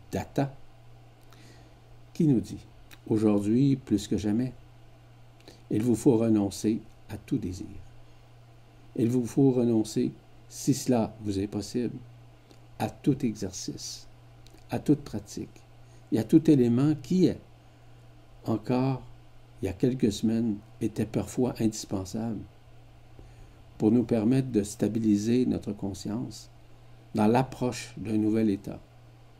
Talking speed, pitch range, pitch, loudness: 115 wpm, 110-120 Hz, 115 Hz, -28 LUFS